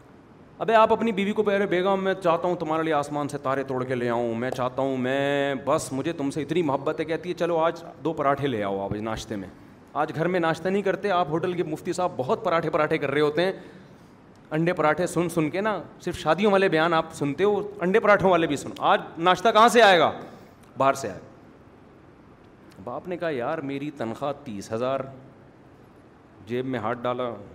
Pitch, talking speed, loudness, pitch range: 155 Hz, 215 wpm, -24 LUFS, 135-180 Hz